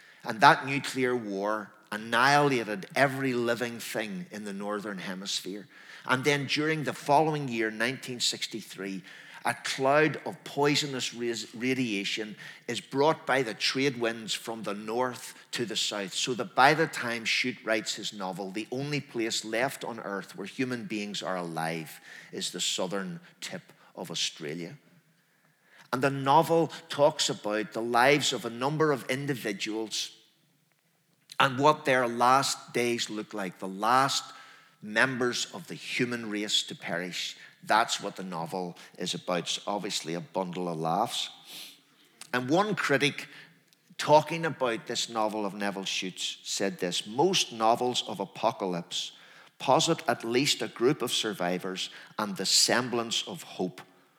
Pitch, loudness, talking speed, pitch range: 120 Hz, -29 LUFS, 145 wpm, 105-140 Hz